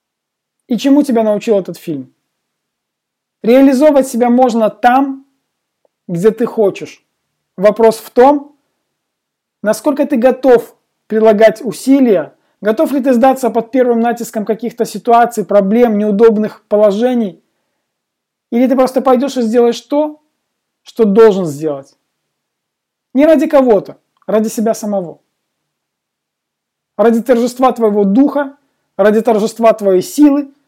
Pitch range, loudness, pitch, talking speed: 215-265 Hz, -12 LUFS, 230 Hz, 110 wpm